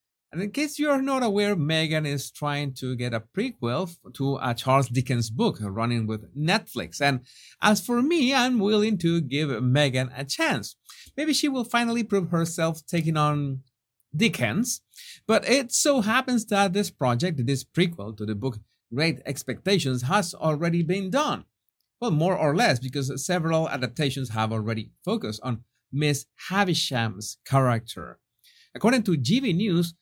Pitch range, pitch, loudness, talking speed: 130-205 Hz, 155 Hz, -25 LUFS, 155 wpm